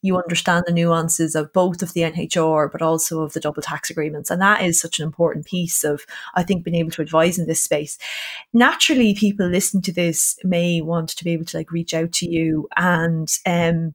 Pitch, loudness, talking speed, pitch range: 170 Hz, -19 LUFS, 220 wpm, 160-180 Hz